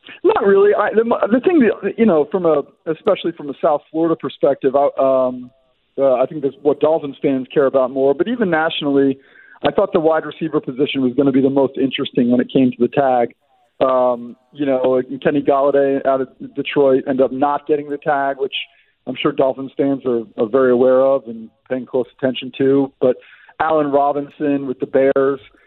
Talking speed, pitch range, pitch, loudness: 200 wpm, 130-155 Hz, 140 Hz, -17 LUFS